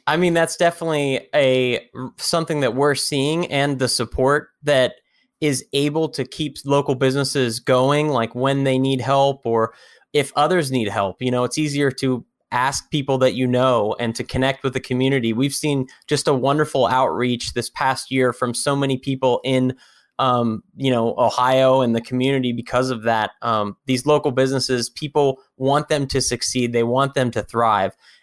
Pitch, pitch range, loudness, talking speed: 130 Hz, 125-140 Hz, -20 LUFS, 180 wpm